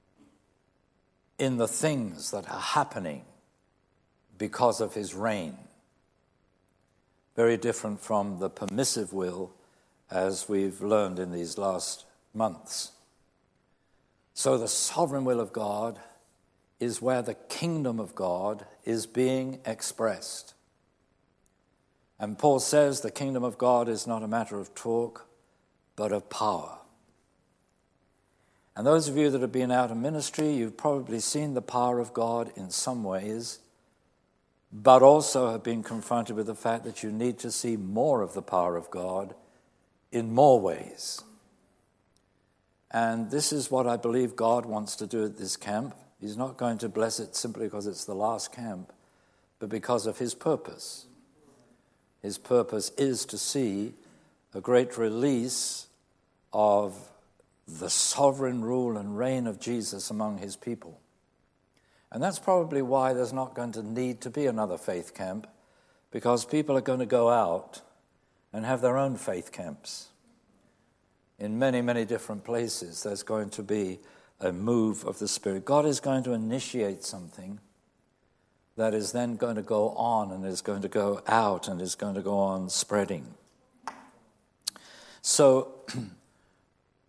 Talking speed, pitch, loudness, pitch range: 145 wpm, 115 Hz, -28 LUFS, 105-125 Hz